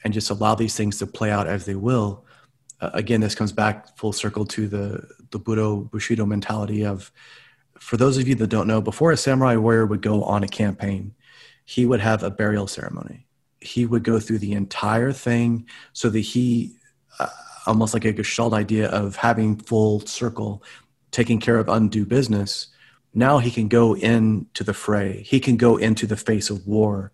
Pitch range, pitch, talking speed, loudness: 105-115 Hz, 110 Hz, 190 wpm, -22 LUFS